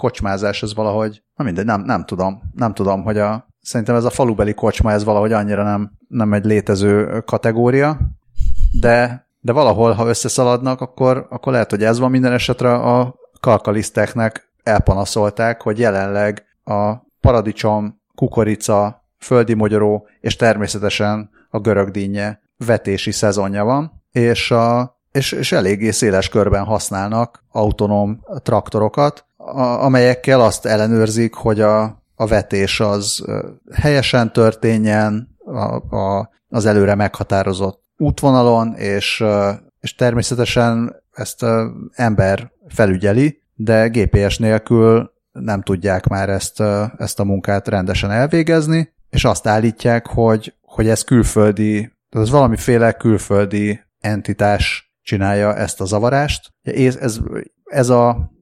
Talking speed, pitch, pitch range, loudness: 120 wpm, 110 Hz, 105-120 Hz, -16 LUFS